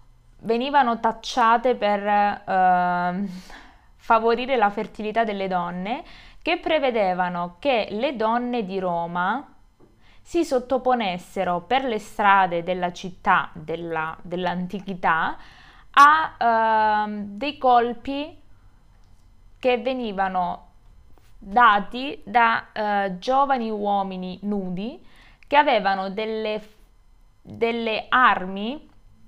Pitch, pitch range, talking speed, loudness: 210 Hz, 185-245 Hz, 85 wpm, -22 LUFS